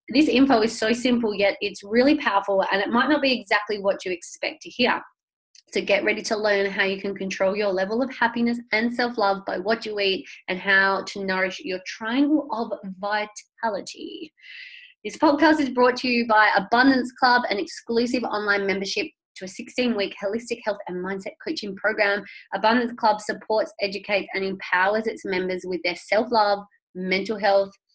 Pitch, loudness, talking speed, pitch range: 215 Hz, -23 LUFS, 185 wpm, 200-250 Hz